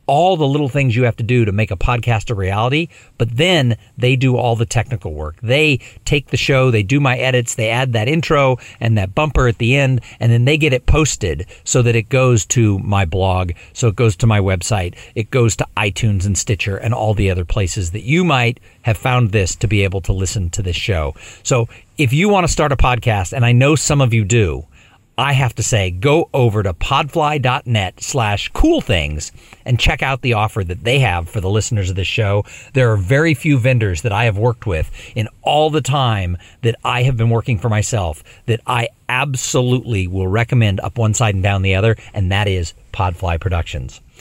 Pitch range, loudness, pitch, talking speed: 100-130 Hz, -16 LUFS, 115 Hz, 220 wpm